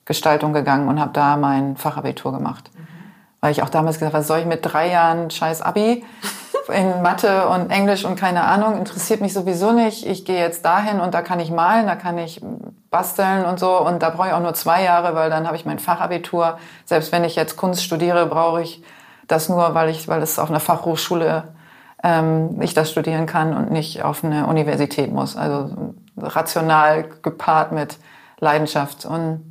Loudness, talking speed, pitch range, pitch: -19 LUFS, 195 wpm, 160-185 Hz, 170 Hz